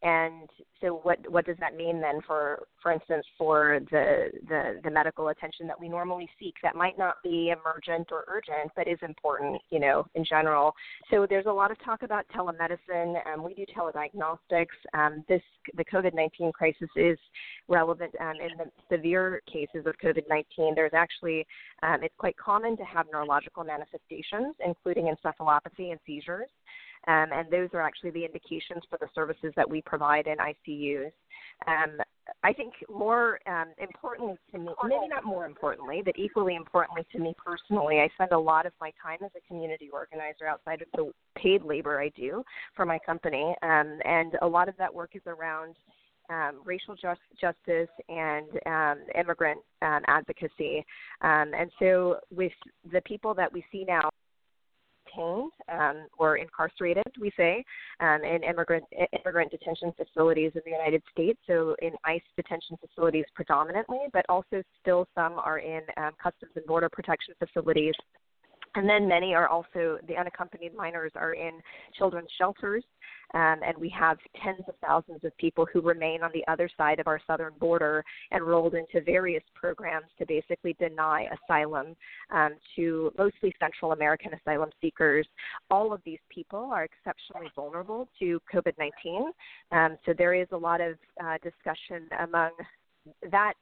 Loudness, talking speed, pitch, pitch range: -29 LUFS, 165 wpm, 170 Hz, 160-180 Hz